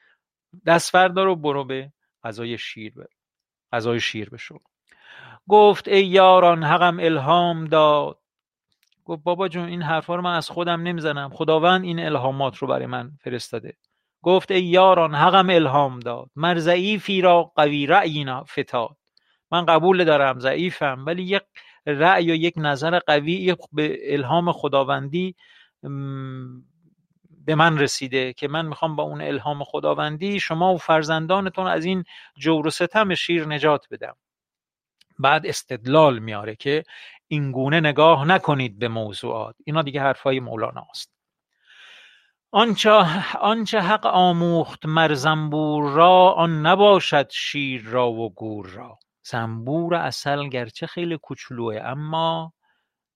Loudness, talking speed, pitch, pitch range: -20 LUFS, 130 wpm, 160 Hz, 140-175 Hz